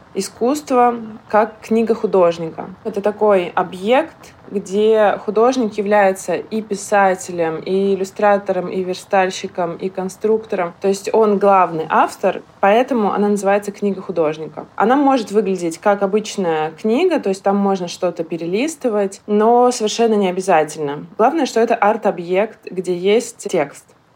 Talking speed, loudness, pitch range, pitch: 125 wpm, -17 LUFS, 185-220 Hz, 200 Hz